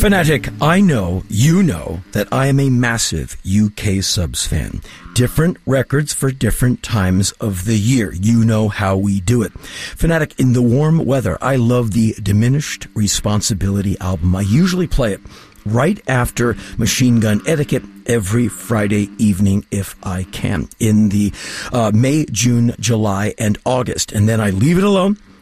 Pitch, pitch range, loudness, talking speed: 115 Hz, 100-130 Hz, -16 LUFS, 160 wpm